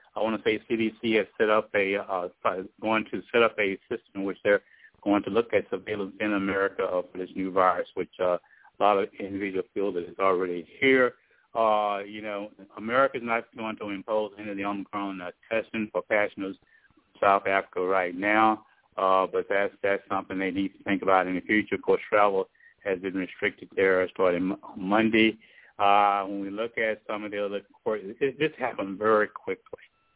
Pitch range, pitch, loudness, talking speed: 95-110 Hz, 100 Hz, -27 LUFS, 185 wpm